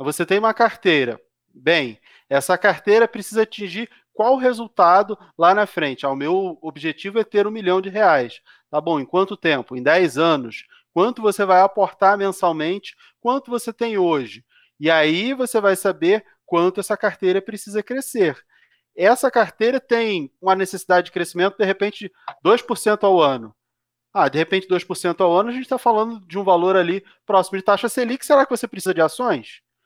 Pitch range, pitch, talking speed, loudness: 180-230 Hz, 195 Hz, 175 wpm, -19 LUFS